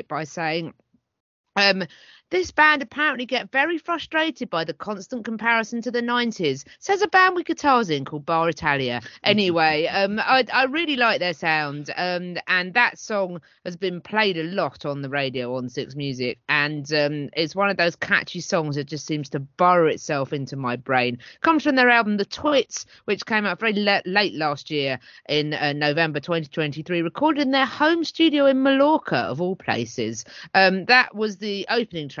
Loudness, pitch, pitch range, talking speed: -22 LUFS, 180 Hz, 150-245 Hz, 185 wpm